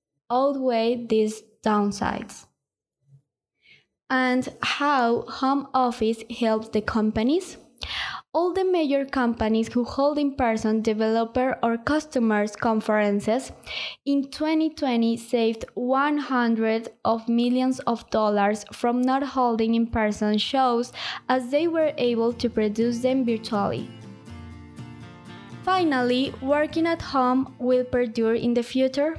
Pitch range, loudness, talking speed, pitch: 225-270 Hz, -24 LUFS, 105 wpm, 240 Hz